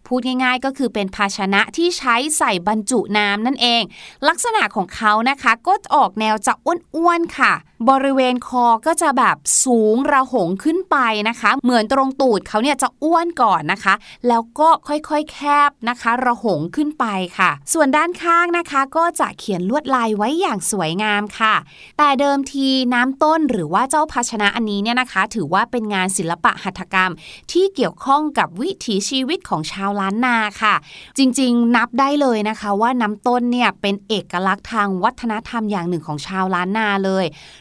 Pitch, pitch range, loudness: 240 Hz, 205-280 Hz, -17 LUFS